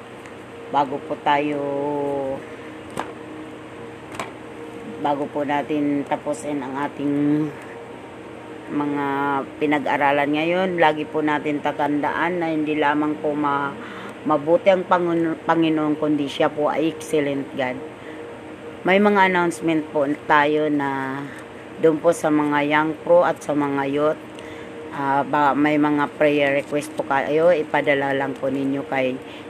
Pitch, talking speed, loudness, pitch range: 150 Hz, 120 wpm, -21 LUFS, 145-155 Hz